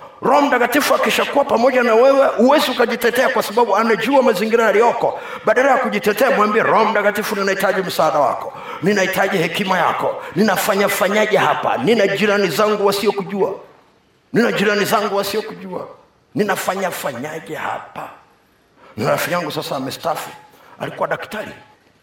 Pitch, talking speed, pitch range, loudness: 215 Hz, 110 wpm, 200-250 Hz, -16 LUFS